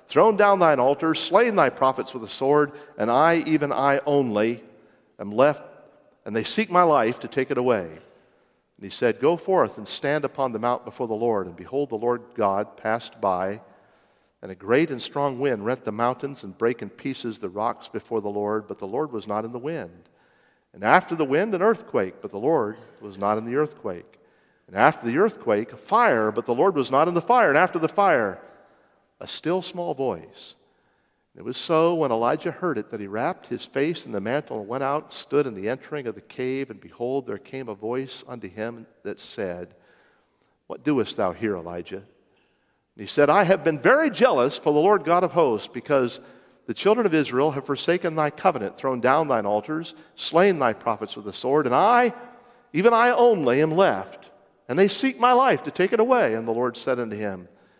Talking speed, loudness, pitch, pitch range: 210 wpm, -23 LUFS, 140 Hz, 115-175 Hz